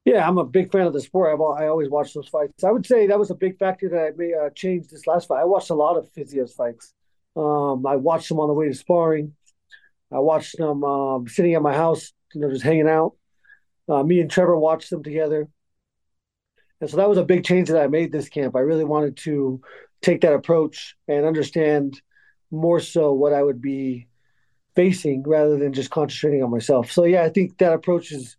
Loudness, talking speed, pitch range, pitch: -21 LUFS, 225 wpm, 145-175 Hz, 155 Hz